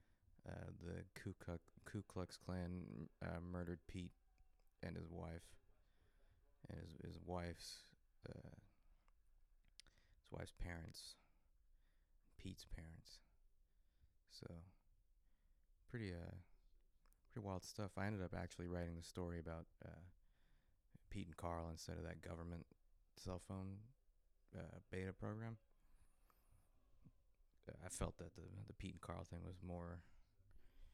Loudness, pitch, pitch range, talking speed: -53 LUFS, 90 Hz, 80-95 Hz, 120 wpm